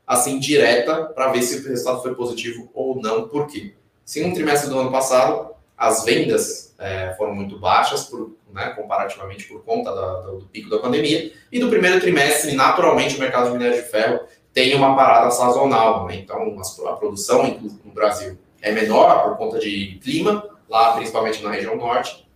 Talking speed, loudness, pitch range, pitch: 185 wpm, -19 LUFS, 105-140 Hz, 120 Hz